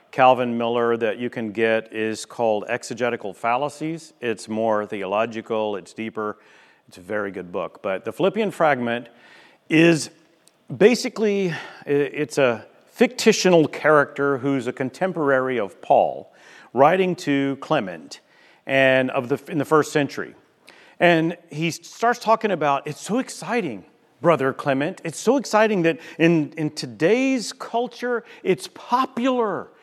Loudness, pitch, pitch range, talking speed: -22 LUFS, 150 Hz, 125-190 Hz, 130 wpm